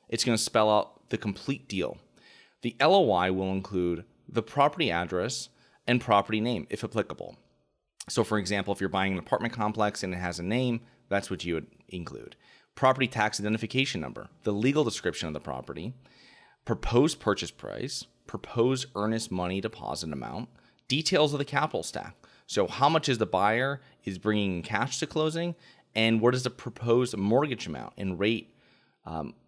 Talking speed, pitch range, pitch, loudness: 170 wpm, 95-125 Hz, 110 Hz, -29 LUFS